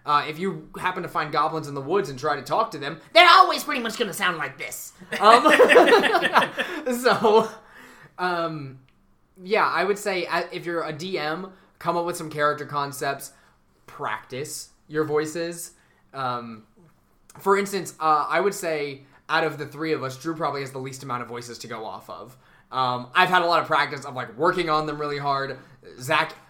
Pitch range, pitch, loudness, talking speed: 140-185 Hz, 160 Hz, -22 LUFS, 195 wpm